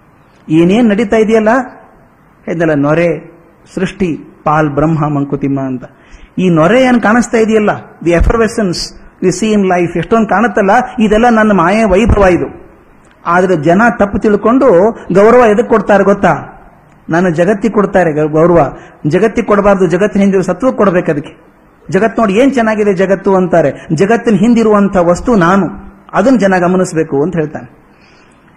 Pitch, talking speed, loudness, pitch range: 190 Hz, 125 wpm, -10 LUFS, 170-220 Hz